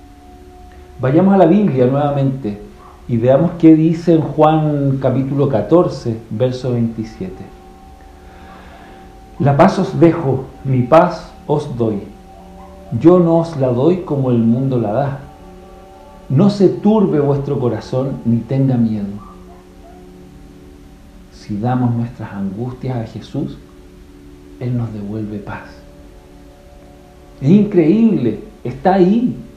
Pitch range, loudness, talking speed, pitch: 95-150 Hz, -15 LUFS, 110 wpm, 120 Hz